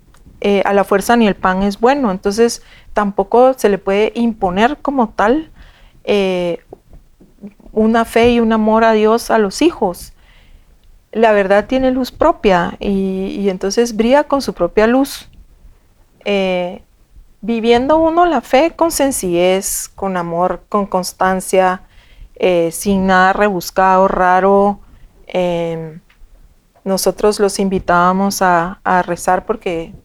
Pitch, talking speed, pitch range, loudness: 200 Hz, 130 wpm, 185-230 Hz, -14 LUFS